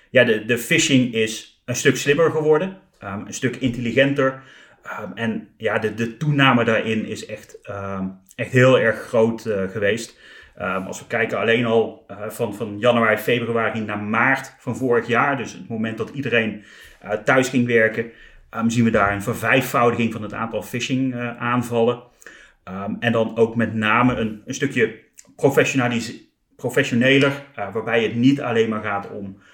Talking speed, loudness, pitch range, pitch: 150 wpm, -20 LUFS, 110-130 Hz, 115 Hz